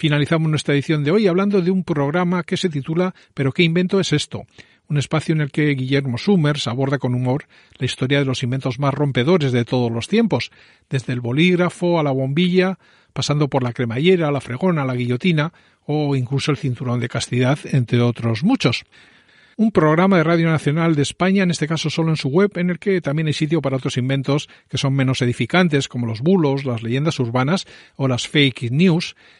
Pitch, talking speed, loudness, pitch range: 145 Hz, 200 wpm, -19 LUFS, 130-175 Hz